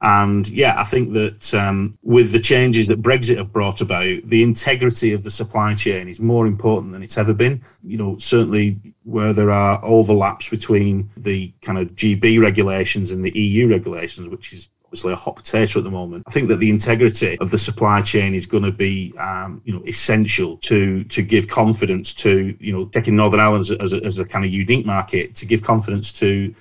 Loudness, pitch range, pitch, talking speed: -17 LUFS, 100-115 Hz, 105 Hz, 210 wpm